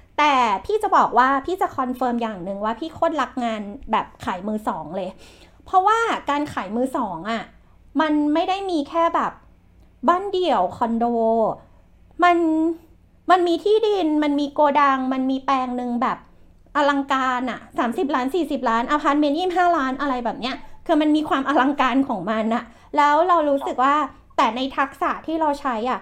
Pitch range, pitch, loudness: 250-330 Hz, 285 Hz, -21 LUFS